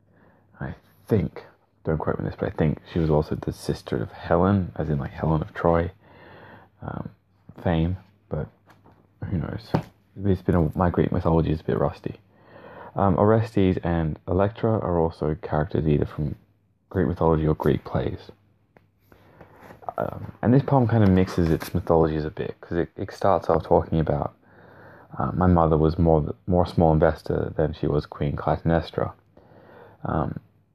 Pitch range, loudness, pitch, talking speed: 80-100 Hz, -24 LUFS, 90 Hz, 160 wpm